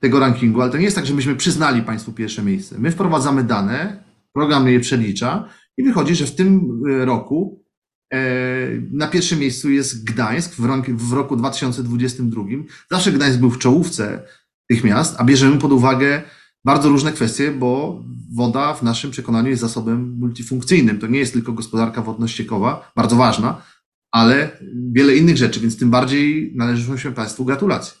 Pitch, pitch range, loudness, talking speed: 130 Hz, 120-145 Hz, -17 LUFS, 165 wpm